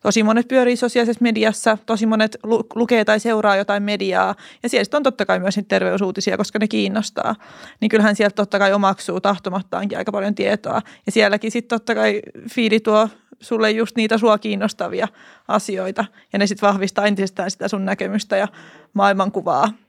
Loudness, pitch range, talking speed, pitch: -19 LUFS, 200-225 Hz, 175 wpm, 215 Hz